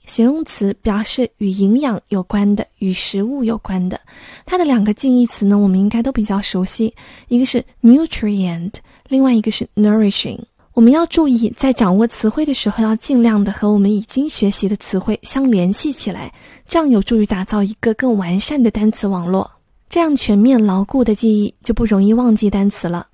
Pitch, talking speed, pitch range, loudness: 220 Hz, 330 characters per minute, 200-245 Hz, -15 LUFS